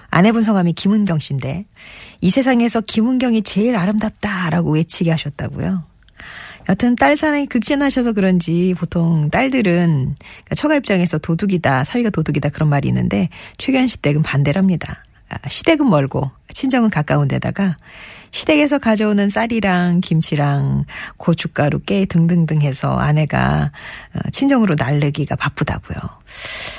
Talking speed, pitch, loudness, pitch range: 325 characters per minute, 180 Hz, -17 LUFS, 150-225 Hz